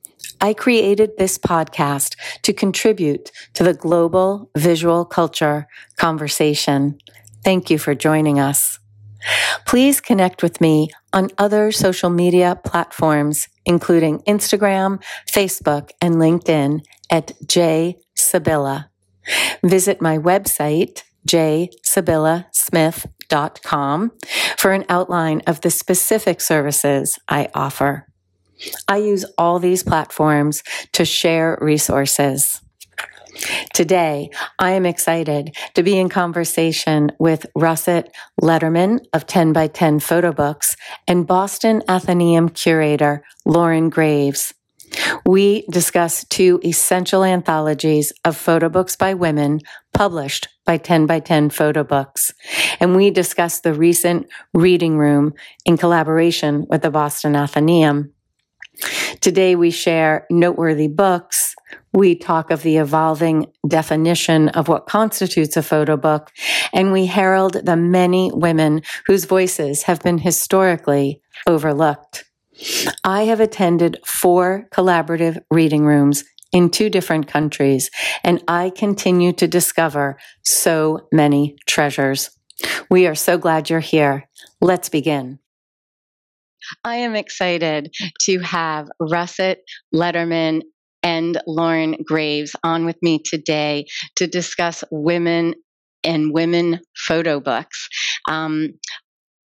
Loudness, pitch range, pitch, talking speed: -17 LUFS, 155-180 Hz, 165 Hz, 110 wpm